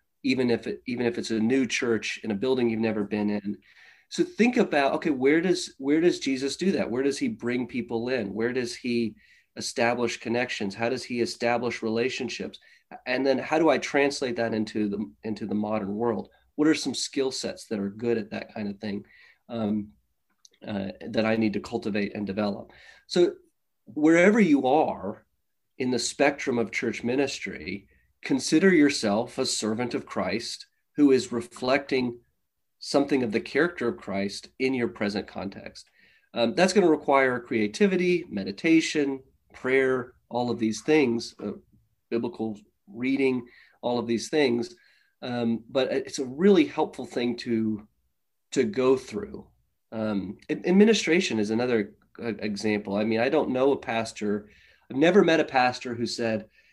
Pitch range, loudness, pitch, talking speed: 110-140 Hz, -26 LUFS, 120 Hz, 165 wpm